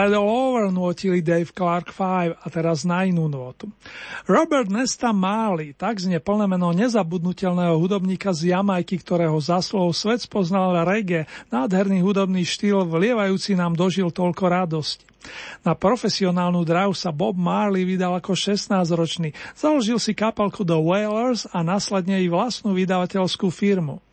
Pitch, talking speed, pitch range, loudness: 185 Hz, 135 wpm, 175-205 Hz, -21 LUFS